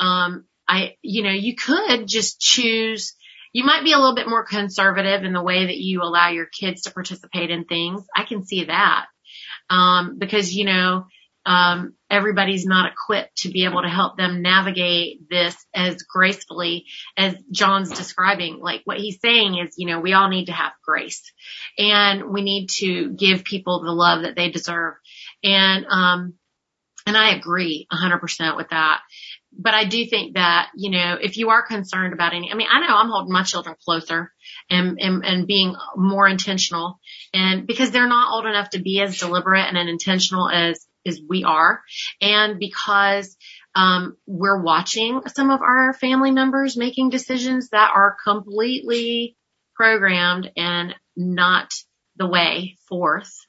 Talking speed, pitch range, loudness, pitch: 170 wpm, 180-210 Hz, -19 LUFS, 190 Hz